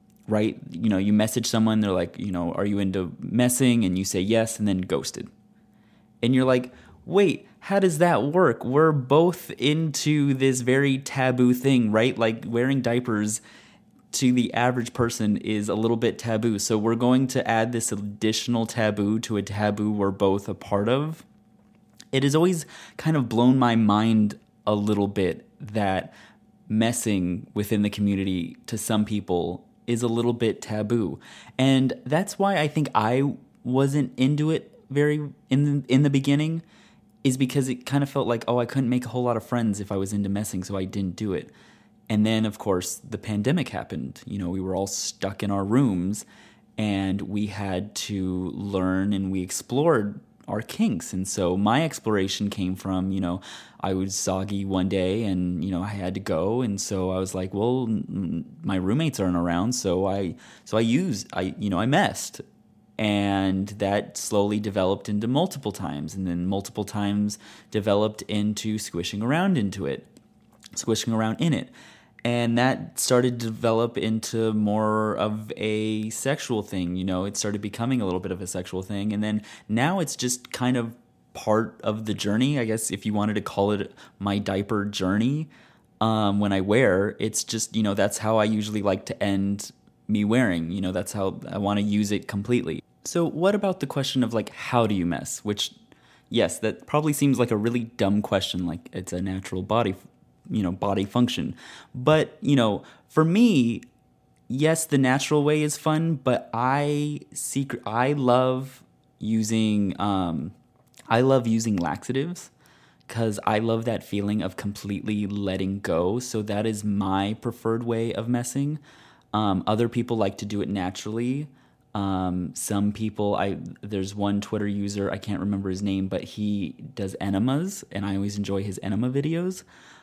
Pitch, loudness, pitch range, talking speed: 110 Hz, -25 LUFS, 100-125 Hz, 180 wpm